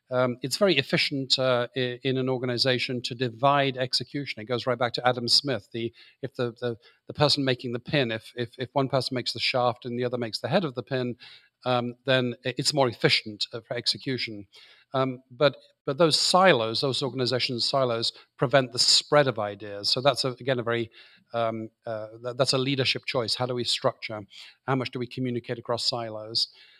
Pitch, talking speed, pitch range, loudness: 125 Hz, 200 wpm, 120-135 Hz, -26 LUFS